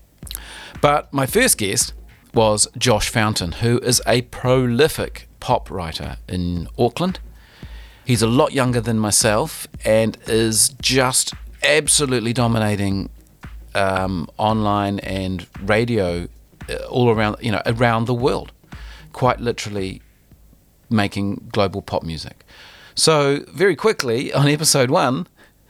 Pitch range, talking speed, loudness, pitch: 95-125 Hz, 115 wpm, -19 LUFS, 110 Hz